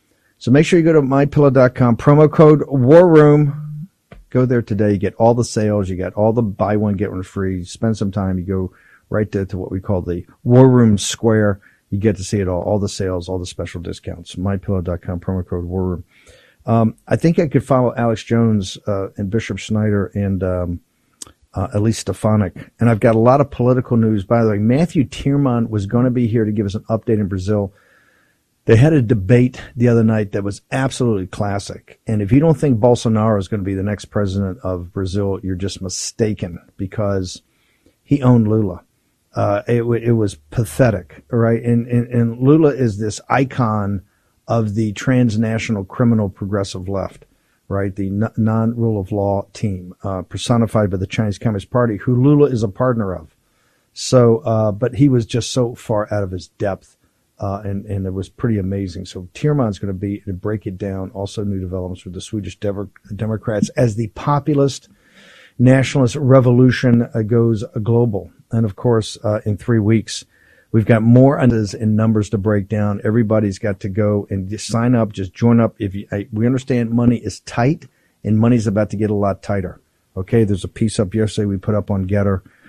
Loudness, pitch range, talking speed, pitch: -17 LUFS, 100-120 Hz, 195 wpm, 110 Hz